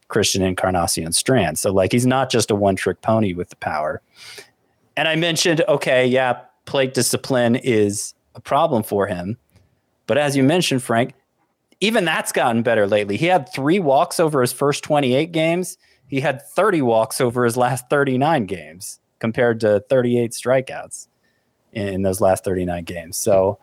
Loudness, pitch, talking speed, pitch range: -19 LUFS, 120 Hz, 165 wpm, 100-135 Hz